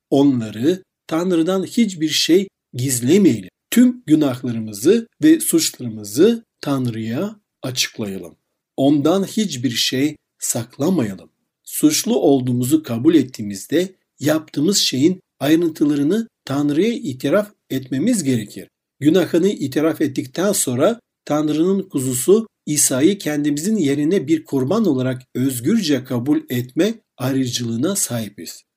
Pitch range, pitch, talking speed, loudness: 130-195 Hz, 150 Hz, 90 wpm, -18 LUFS